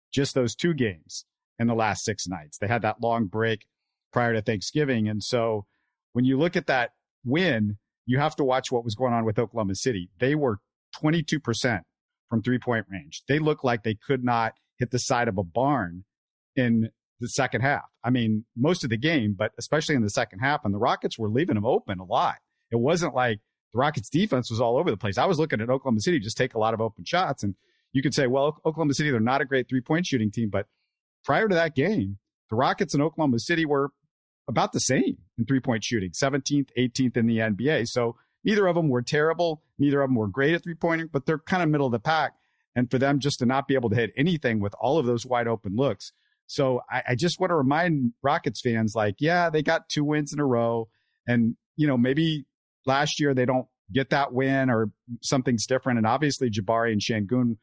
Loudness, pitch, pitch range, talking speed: -25 LUFS, 125 Hz, 115-145 Hz, 230 wpm